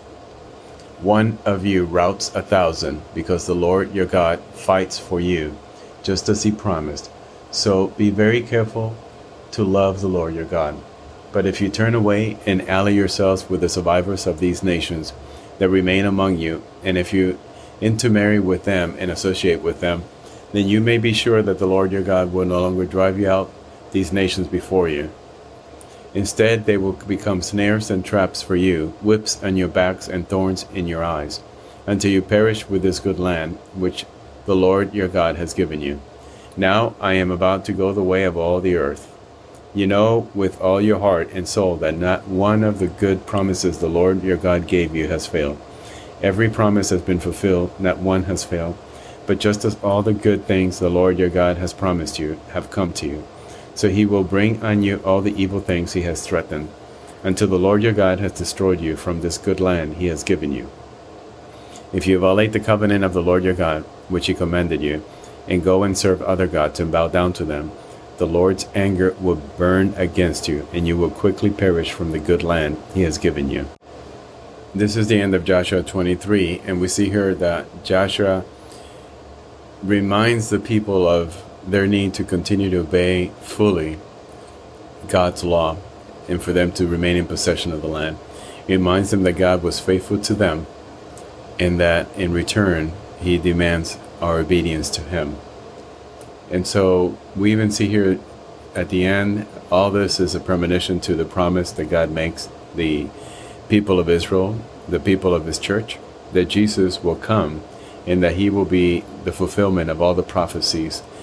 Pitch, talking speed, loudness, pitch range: 95 Hz, 185 wpm, -19 LUFS, 90-100 Hz